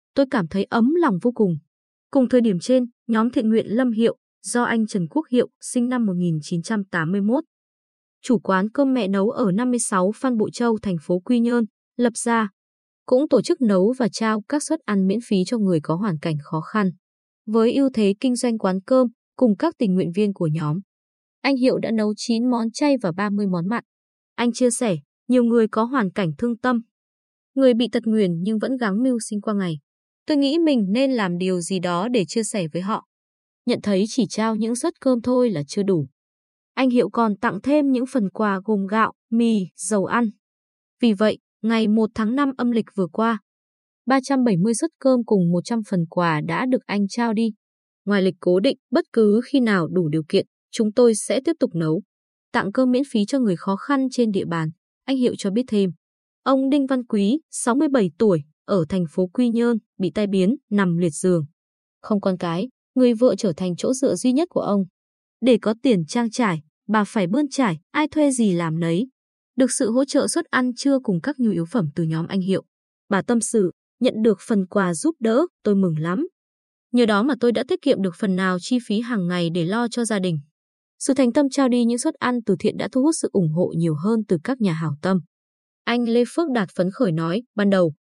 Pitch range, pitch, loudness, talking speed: 190-250 Hz, 220 Hz, -21 LUFS, 215 wpm